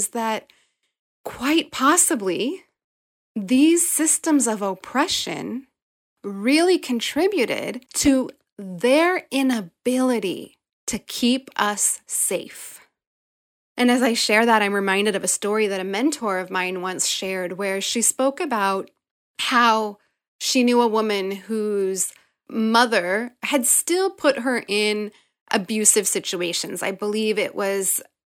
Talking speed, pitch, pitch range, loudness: 120 wpm, 225 Hz, 200-270 Hz, -21 LUFS